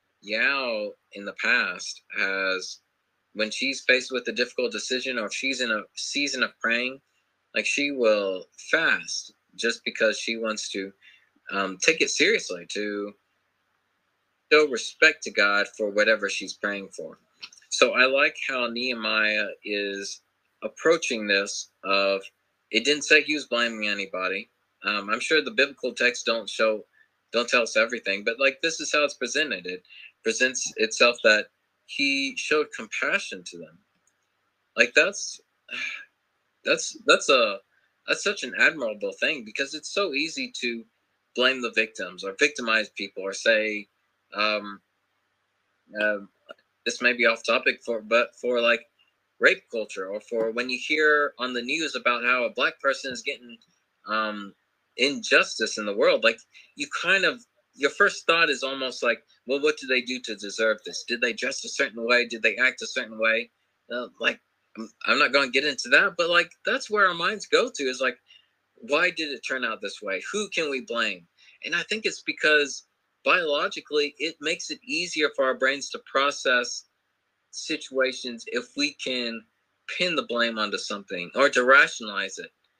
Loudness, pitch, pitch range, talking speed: -24 LUFS, 120 Hz, 105-150 Hz, 170 wpm